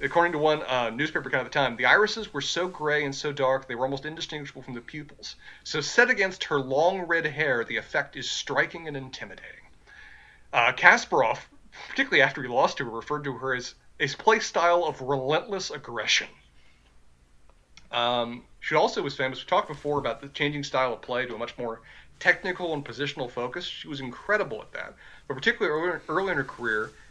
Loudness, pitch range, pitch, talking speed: -26 LUFS, 130-170 Hz, 145 Hz, 195 wpm